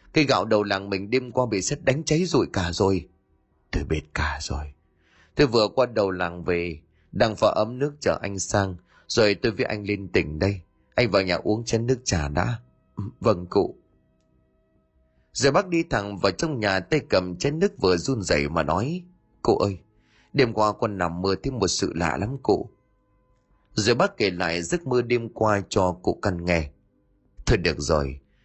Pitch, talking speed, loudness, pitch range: 100 Hz, 195 wpm, -24 LUFS, 85-120 Hz